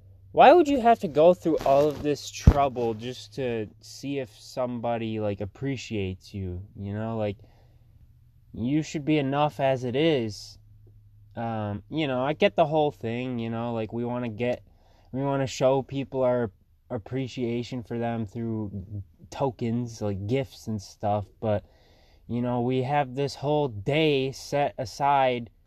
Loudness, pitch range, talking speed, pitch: -26 LUFS, 105-135 Hz, 160 wpm, 120 Hz